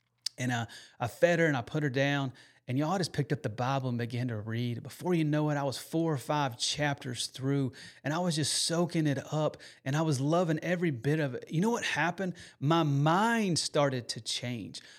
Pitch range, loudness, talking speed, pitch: 130-165 Hz, -31 LUFS, 225 wpm, 145 Hz